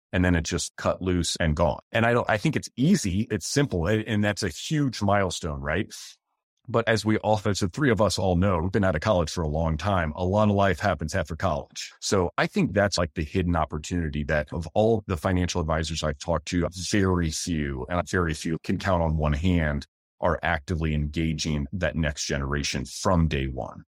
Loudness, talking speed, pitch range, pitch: -25 LUFS, 220 wpm, 80-100 Hz, 90 Hz